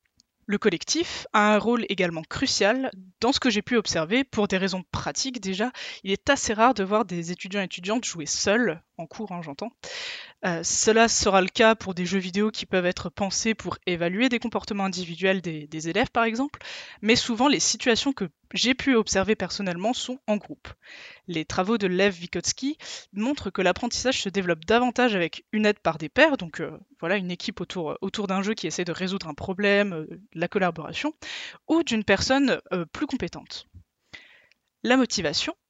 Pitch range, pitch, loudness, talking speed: 180-240 Hz, 205 Hz, -25 LUFS, 190 wpm